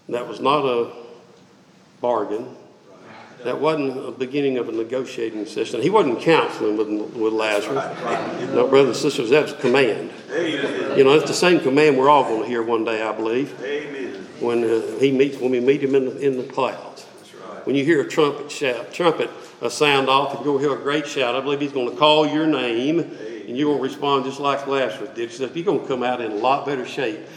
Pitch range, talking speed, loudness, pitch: 115-140 Hz, 215 wpm, -20 LUFS, 135 Hz